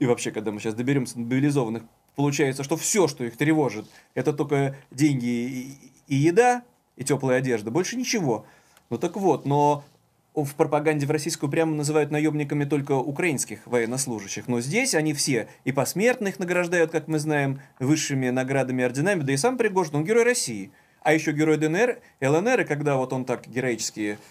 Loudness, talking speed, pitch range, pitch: -24 LUFS, 170 wpm, 125-155 Hz, 145 Hz